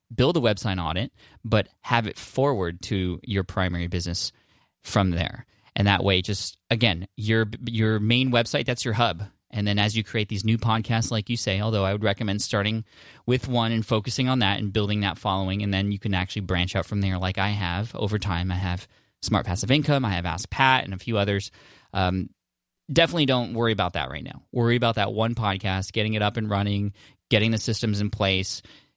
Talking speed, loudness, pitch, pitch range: 210 wpm, -25 LUFS, 105 Hz, 95-115 Hz